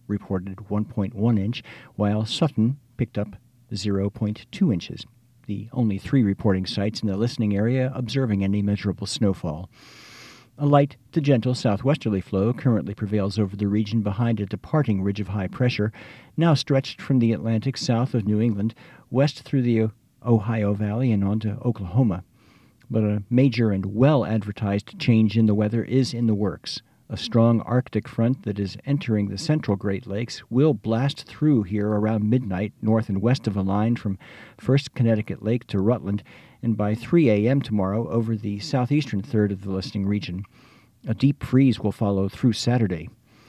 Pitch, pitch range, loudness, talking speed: 110 Hz, 105-125 Hz, -23 LUFS, 165 wpm